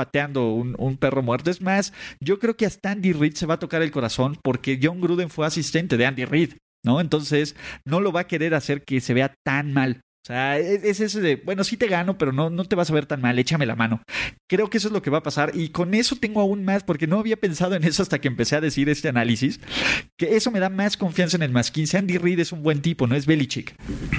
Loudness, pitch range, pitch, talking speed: -23 LUFS, 135-185 Hz, 160 Hz, 270 wpm